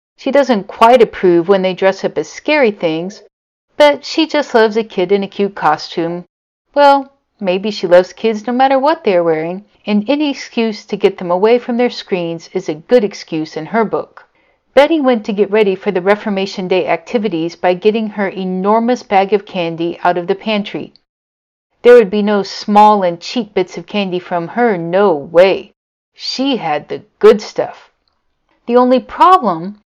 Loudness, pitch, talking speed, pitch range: -13 LUFS, 205 Hz, 185 wpm, 180-245 Hz